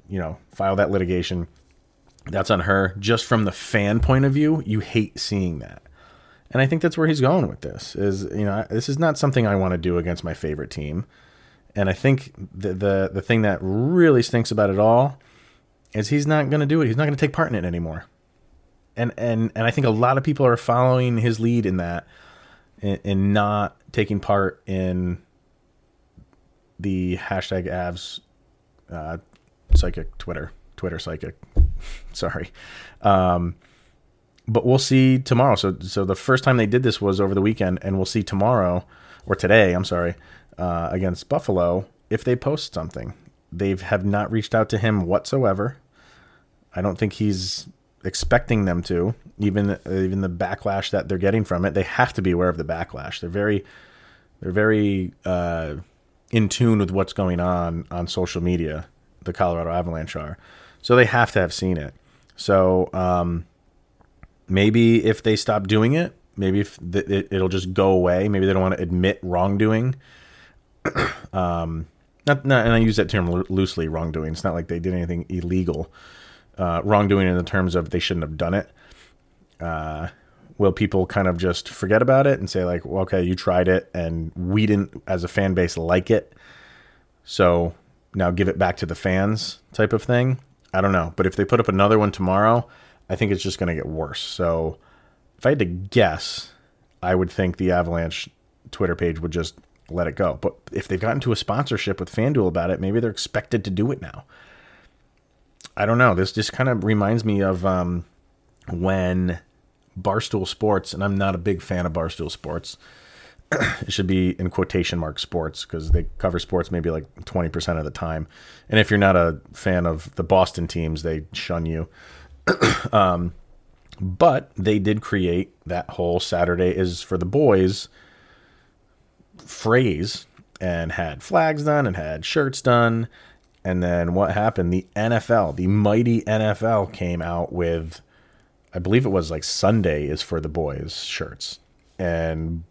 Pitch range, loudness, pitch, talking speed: 85-110 Hz, -22 LUFS, 95 Hz, 180 wpm